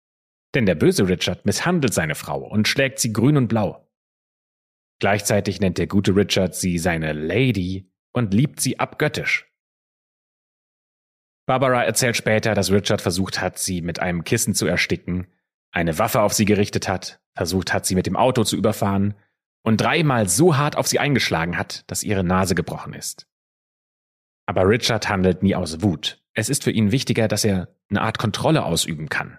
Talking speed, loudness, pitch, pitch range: 170 wpm, -20 LUFS, 100 Hz, 95-115 Hz